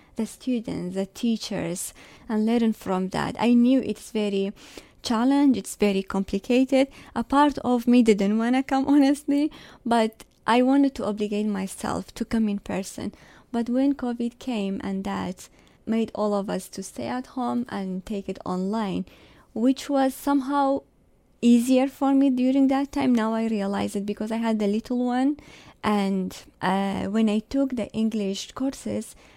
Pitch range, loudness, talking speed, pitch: 200-260 Hz, -24 LUFS, 165 wpm, 225 Hz